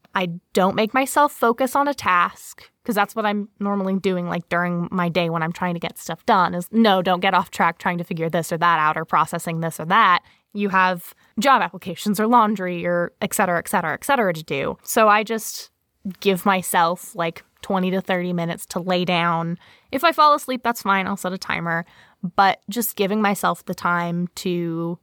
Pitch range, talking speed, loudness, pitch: 175-210 Hz, 215 wpm, -21 LUFS, 185 Hz